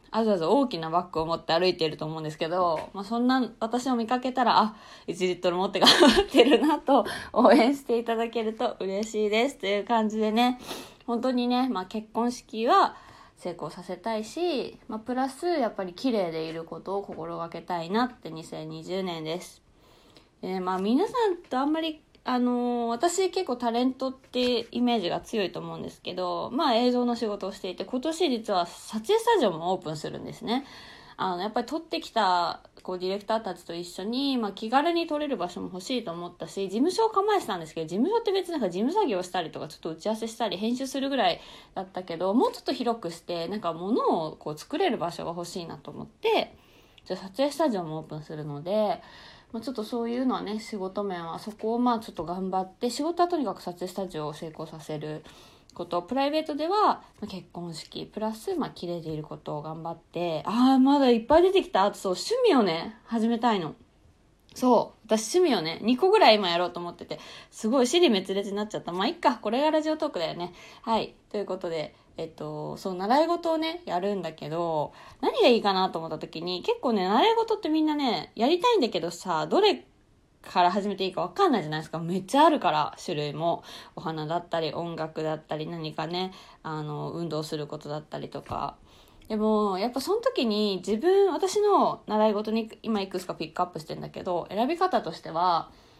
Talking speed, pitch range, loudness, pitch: 410 characters per minute, 175-255 Hz, -27 LUFS, 215 Hz